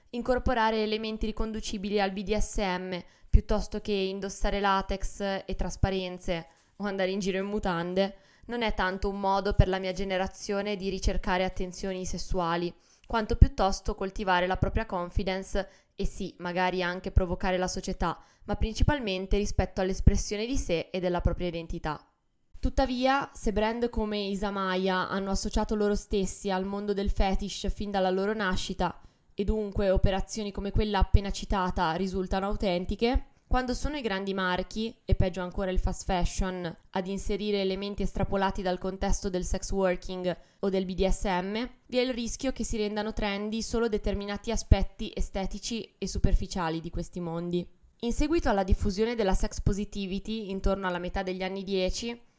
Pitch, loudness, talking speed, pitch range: 195 Hz, -30 LUFS, 150 wpm, 185-210 Hz